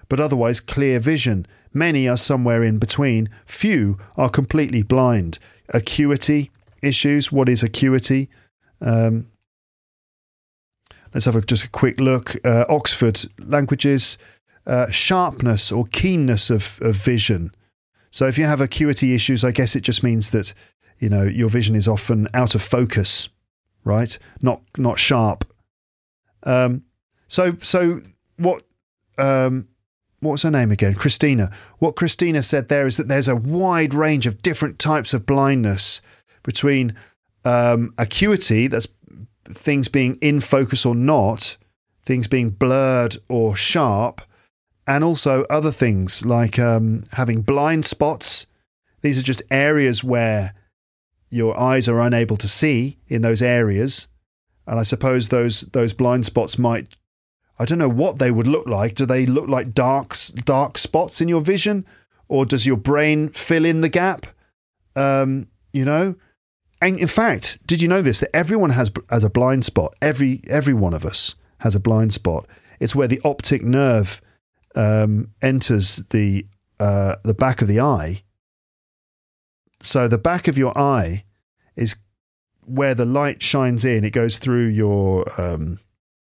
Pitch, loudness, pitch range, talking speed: 125 Hz, -19 LUFS, 110-140 Hz, 150 wpm